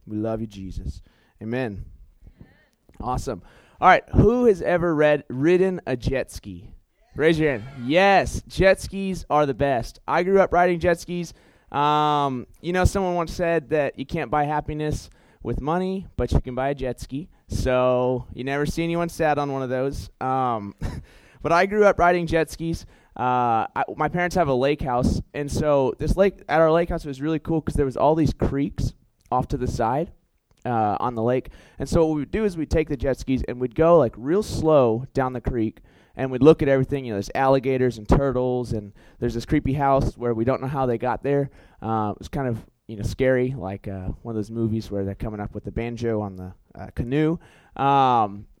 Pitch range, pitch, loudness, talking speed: 115-155 Hz, 135 Hz, -23 LUFS, 220 wpm